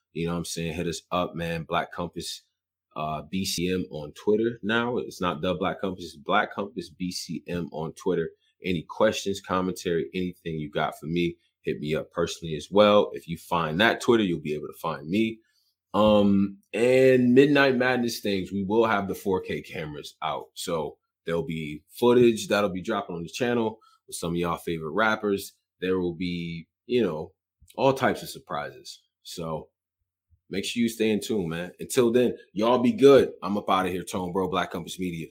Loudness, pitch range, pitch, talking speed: -26 LUFS, 85-110 Hz, 95 Hz, 190 wpm